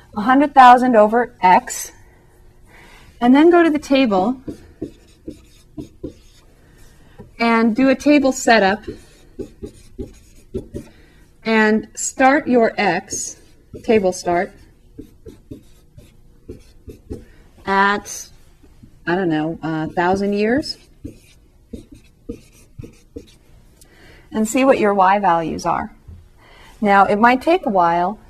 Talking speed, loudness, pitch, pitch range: 85 wpm, -16 LUFS, 220 Hz, 185-260 Hz